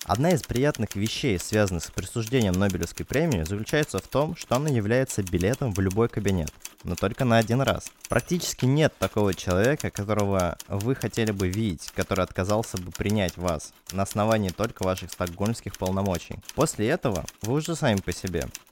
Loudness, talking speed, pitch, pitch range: -26 LUFS, 165 wpm, 105 Hz, 95-115 Hz